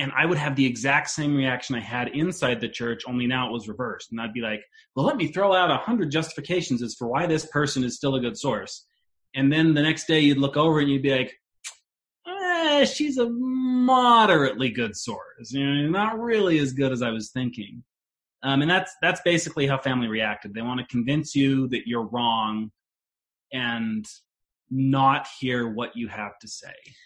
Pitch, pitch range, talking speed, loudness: 135 Hz, 120-160 Hz, 200 wpm, -24 LUFS